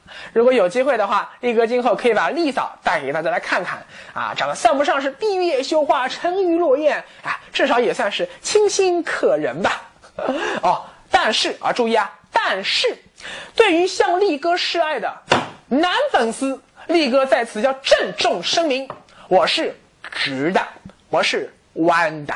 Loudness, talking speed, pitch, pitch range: -19 LUFS, 230 characters per minute, 335 Hz, 265-390 Hz